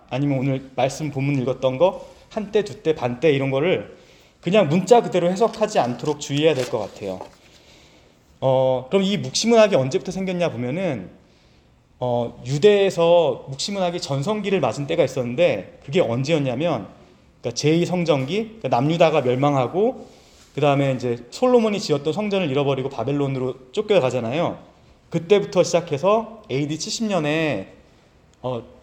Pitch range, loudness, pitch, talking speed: 130-190 Hz, -21 LUFS, 150 Hz, 330 characters per minute